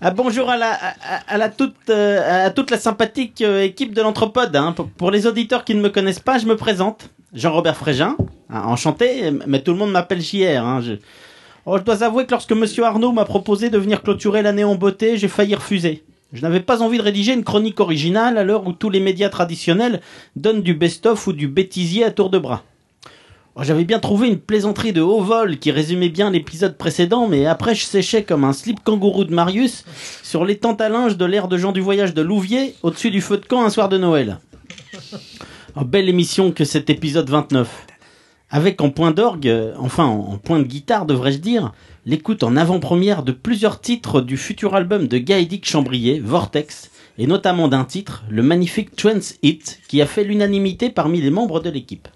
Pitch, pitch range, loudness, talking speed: 195 Hz, 155-220 Hz, -18 LUFS, 210 wpm